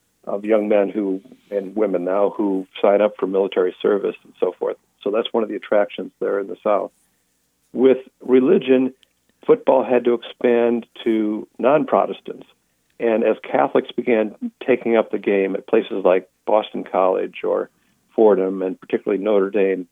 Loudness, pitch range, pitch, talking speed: -20 LUFS, 95-130 Hz, 110 Hz, 160 wpm